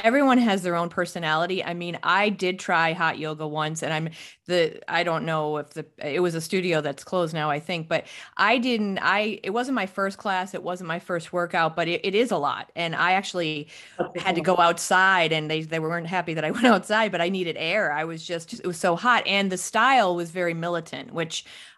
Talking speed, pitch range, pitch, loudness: 230 wpm, 160-190 Hz, 175 Hz, -24 LUFS